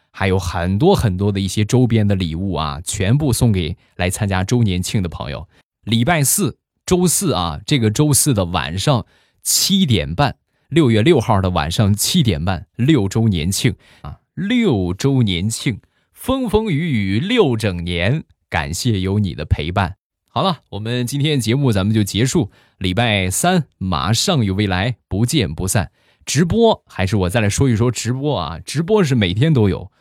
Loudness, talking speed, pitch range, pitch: -17 LUFS, 245 characters per minute, 95-140 Hz, 110 Hz